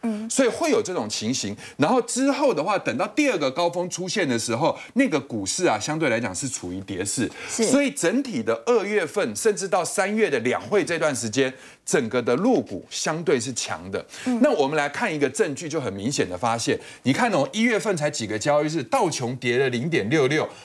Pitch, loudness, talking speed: 200 Hz, -23 LUFS, 310 characters per minute